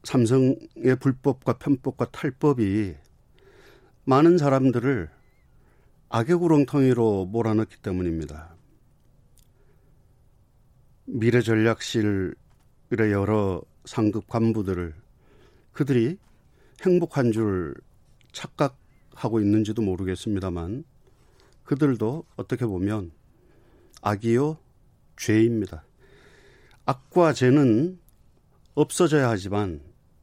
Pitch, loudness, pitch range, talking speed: 115 Hz, -24 LUFS, 100-135 Hz, 190 characters per minute